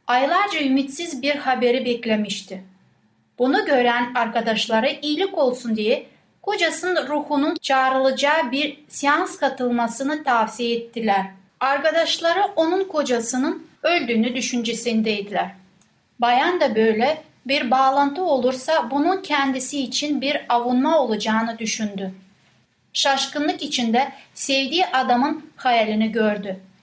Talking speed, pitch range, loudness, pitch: 95 wpm, 230-295 Hz, -21 LUFS, 260 Hz